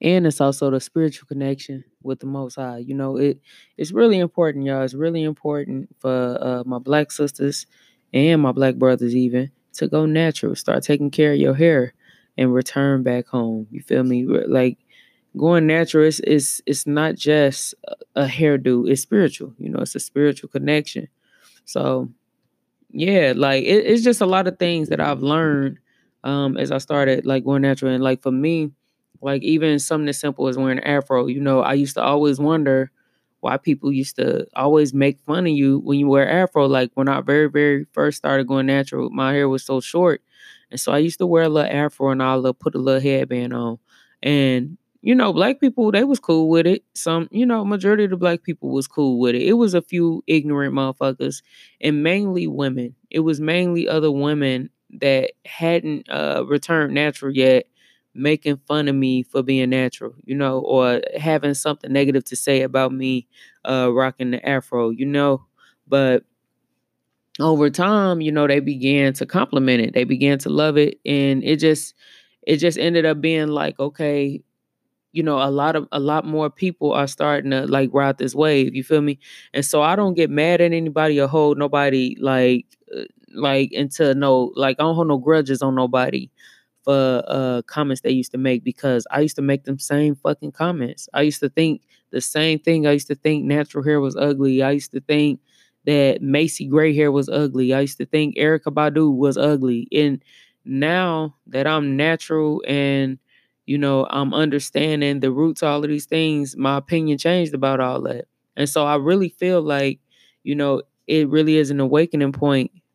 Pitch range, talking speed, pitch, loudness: 135-155 Hz, 195 wpm, 145 Hz, -19 LUFS